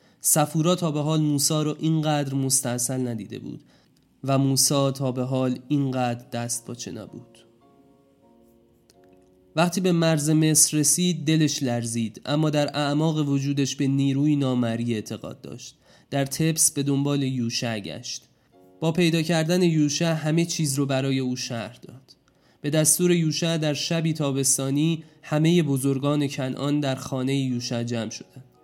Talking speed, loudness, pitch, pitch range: 140 wpm, -23 LUFS, 140 Hz, 125-155 Hz